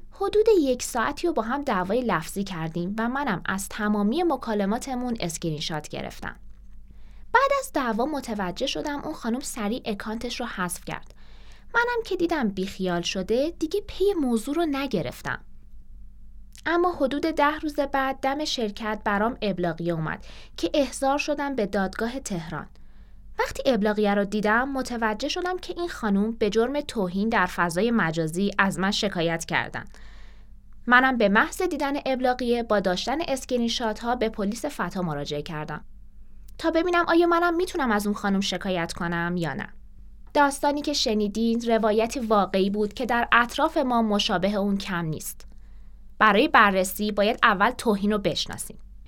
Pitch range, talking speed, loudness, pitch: 195-280 Hz, 150 wpm, -25 LUFS, 230 Hz